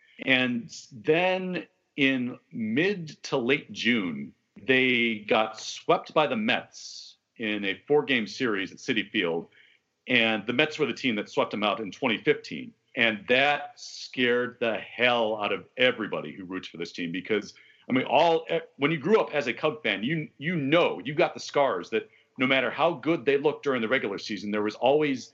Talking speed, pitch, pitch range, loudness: 185 wpm, 140 Hz, 115-165 Hz, -26 LUFS